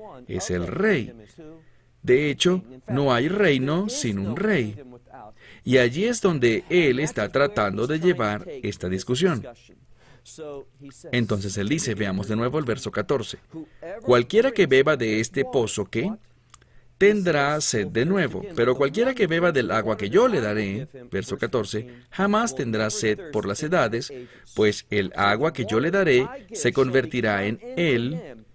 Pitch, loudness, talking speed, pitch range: 125 Hz, -23 LUFS, 150 wpm, 110-160 Hz